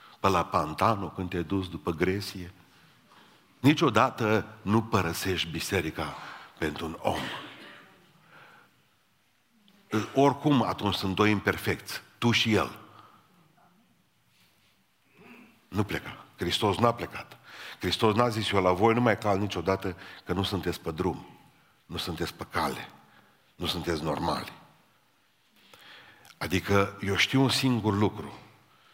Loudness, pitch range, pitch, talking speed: -28 LUFS, 90-110 Hz, 100 Hz, 115 wpm